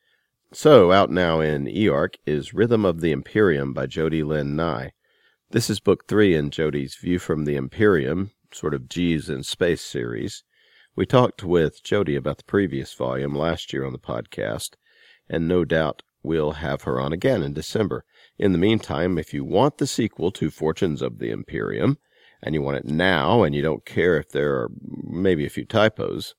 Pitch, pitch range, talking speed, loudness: 75 Hz, 70-85 Hz, 185 wpm, -22 LUFS